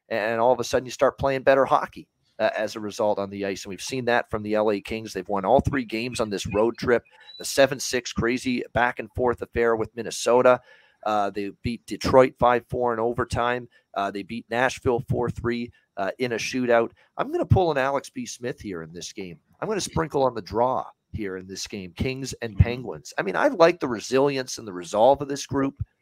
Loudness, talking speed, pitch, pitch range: -24 LUFS, 230 wpm, 120 Hz, 105-130 Hz